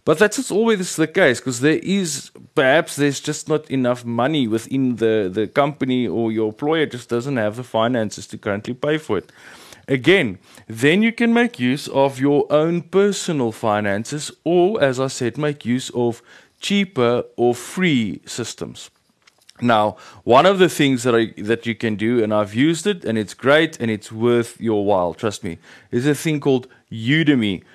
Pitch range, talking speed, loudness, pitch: 115-155 Hz, 180 wpm, -19 LUFS, 130 Hz